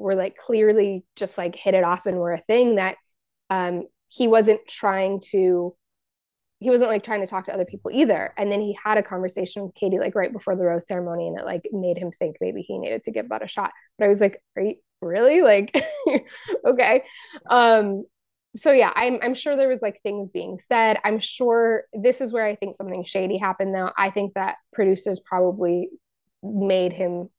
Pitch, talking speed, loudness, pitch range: 200 Hz, 210 wpm, -22 LUFS, 185-225 Hz